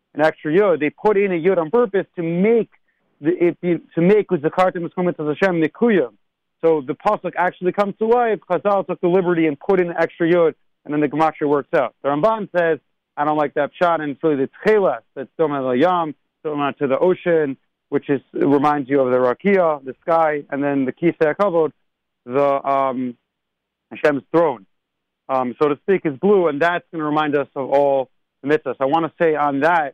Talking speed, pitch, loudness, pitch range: 205 wpm, 160 Hz, -19 LUFS, 145-180 Hz